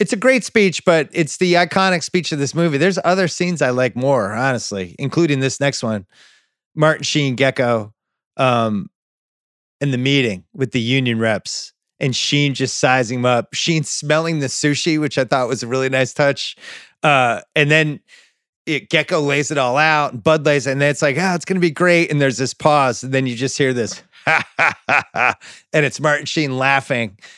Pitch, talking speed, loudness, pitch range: 140 Hz, 200 wpm, -17 LUFS, 130-160 Hz